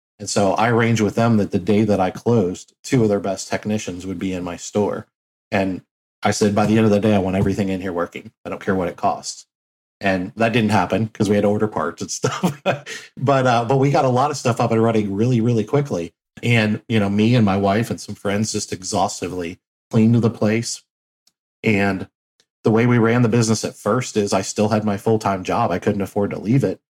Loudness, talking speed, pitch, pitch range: -19 LUFS, 240 wpm, 105 Hz, 100-115 Hz